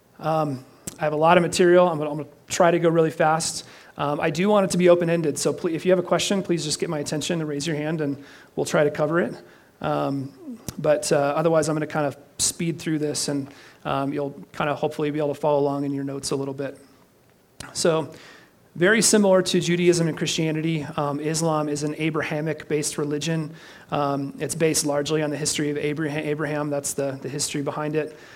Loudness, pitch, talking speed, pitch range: -23 LUFS, 150 Hz, 220 wpm, 145-165 Hz